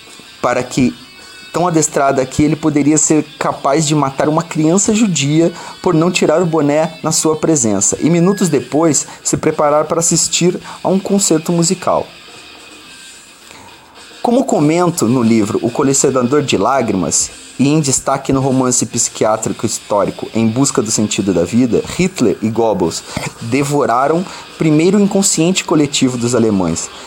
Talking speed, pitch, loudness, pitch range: 140 wpm, 155 Hz, -14 LUFS, 130-170 Hz